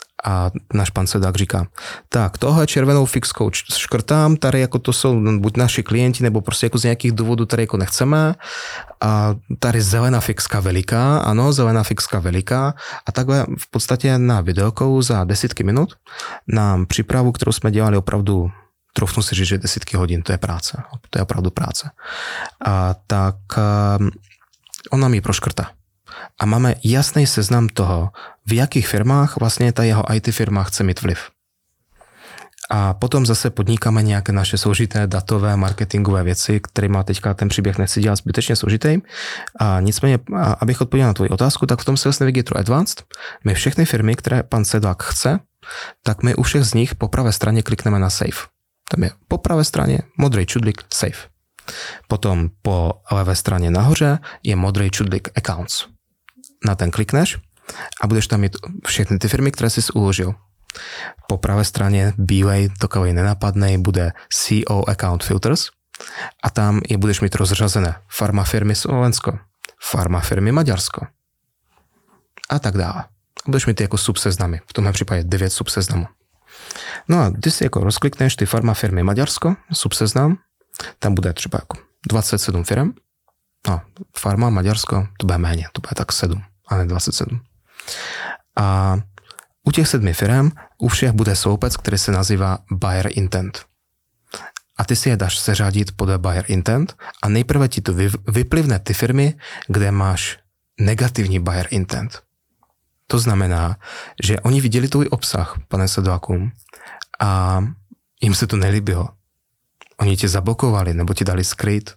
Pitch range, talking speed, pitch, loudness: 95-120 Hz, 155 wpm, 105 Hz, -18 LUFS